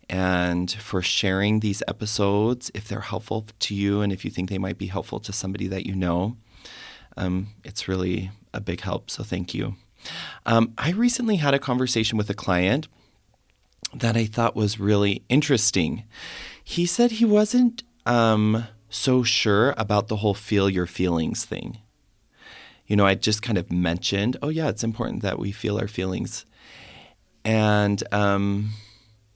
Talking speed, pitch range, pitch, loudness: 160 wpm, 95-115 Hz, 105 Hz, -24 LUFS